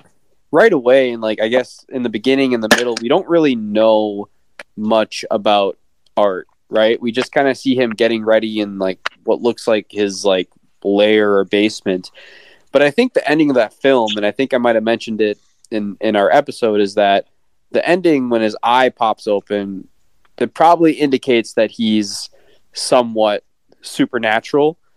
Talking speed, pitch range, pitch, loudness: 180 wpm, 105-130 Hz, 110 Hz, -16 LUFS